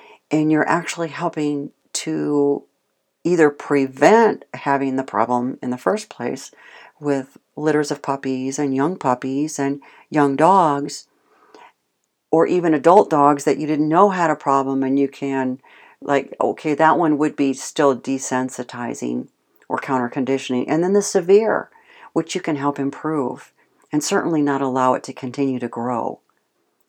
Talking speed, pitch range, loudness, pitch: 150 wpm, 135-155 Hz, -19 LUFS, 140 Hz